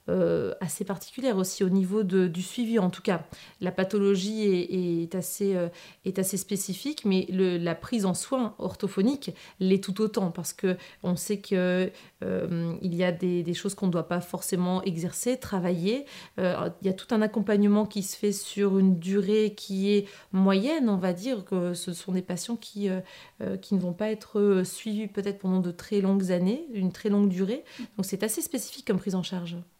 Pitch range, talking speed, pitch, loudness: 185-210 Hz, 200 wpm, 195 Hz, -28 LUFS